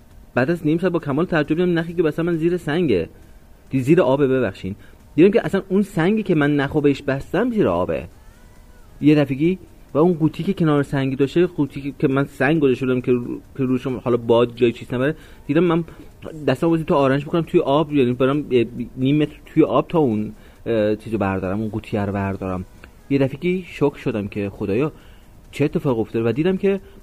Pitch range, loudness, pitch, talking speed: 115-160 Hz, -20 LUFS, 140 Hz, 190 wpm